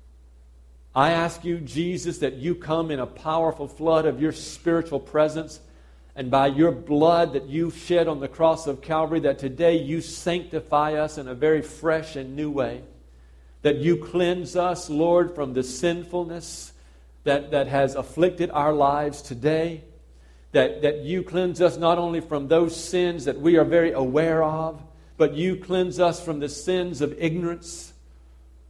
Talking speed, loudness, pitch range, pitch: 165 wpm, -24 LUFS, 135-170 Hz, 155 Hz